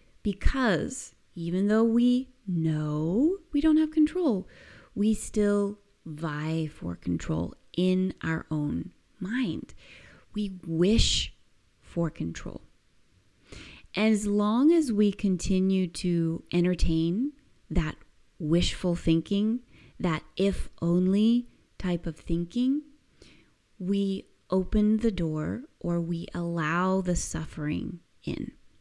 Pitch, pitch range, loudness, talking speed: 185 Hz, 165-215 Hz, -28 LUFS, 100 wpm